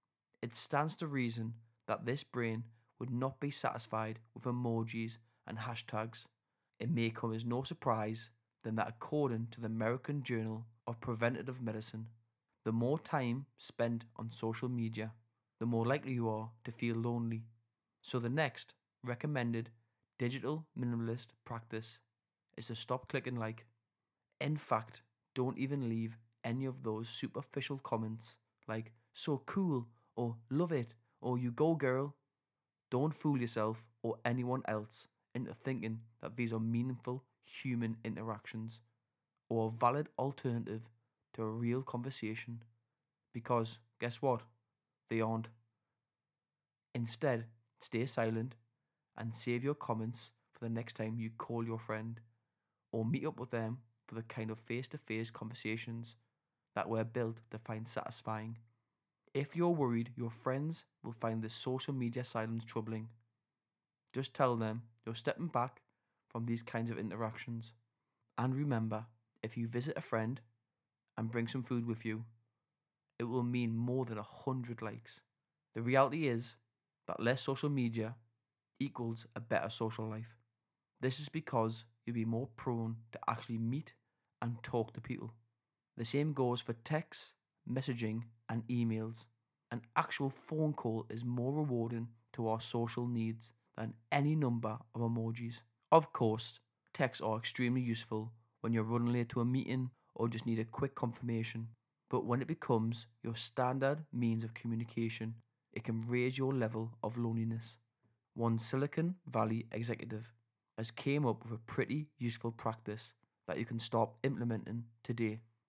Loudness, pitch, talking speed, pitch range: -39 LUFS, 115 Hz, 145 wpm, 115-125 Hz